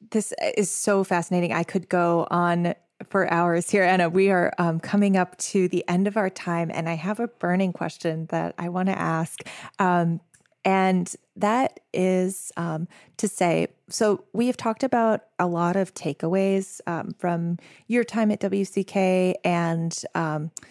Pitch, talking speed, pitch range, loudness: 185 Hz, 170 wpm, 170-200 Hz, -24 LUFS